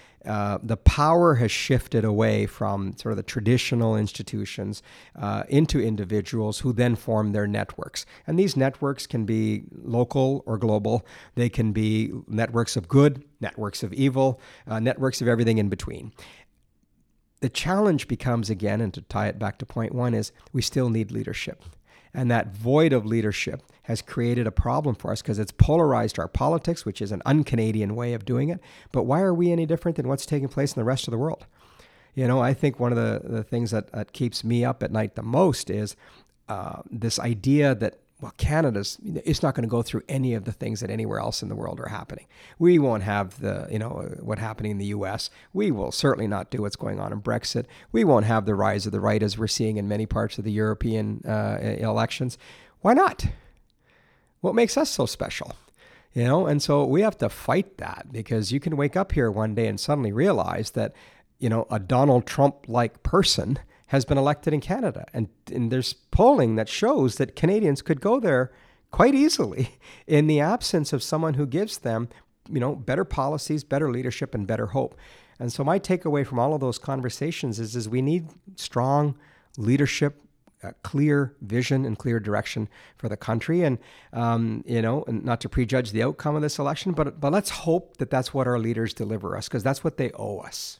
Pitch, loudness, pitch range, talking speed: 120 Hz, -25 LUFS, 110-140 Hz, 200 wpm